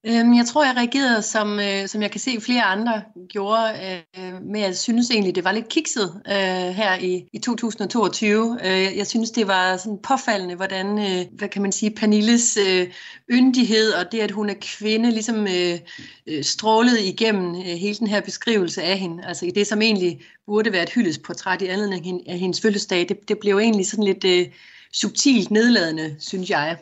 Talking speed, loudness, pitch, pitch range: 165 wpm, -20 LUFS, 205 Hz, 185-225 Hz